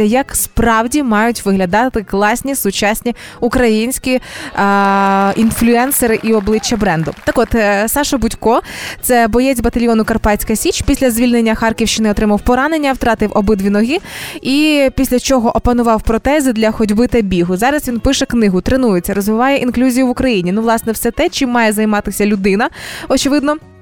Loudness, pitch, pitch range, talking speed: -13 LUFS, 230 Hz, 215-255 Hz, 140 wpm